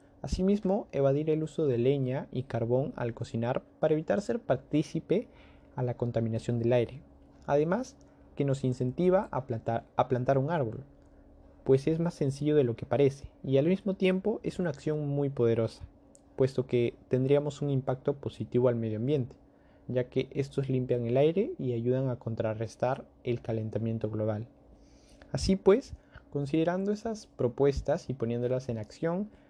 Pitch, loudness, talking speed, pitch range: 130 Hz, -30 LUFS, 155 wpm, 120-150 Hz